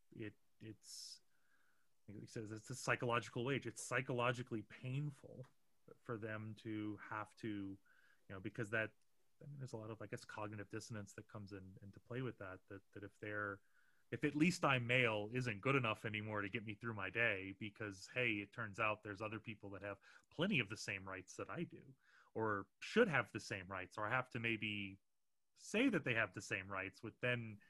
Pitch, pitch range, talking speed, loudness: 110 Hz, 105-120 Hz, 205 wpm, -43 LUFS